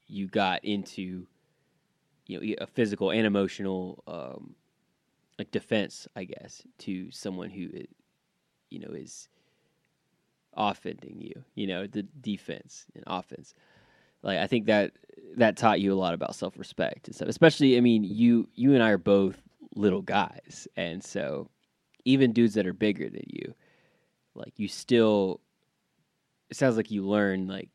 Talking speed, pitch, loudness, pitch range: 155 wpm, 105 Hz, -27 LUFS, 95-115 Hz